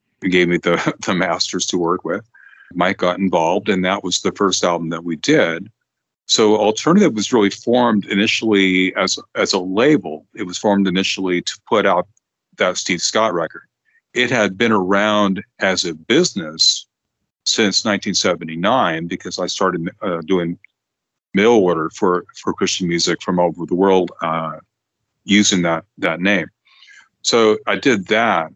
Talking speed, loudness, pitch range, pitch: 160 wpm, -17 LUFS, 90-100 Hz, 95 Hz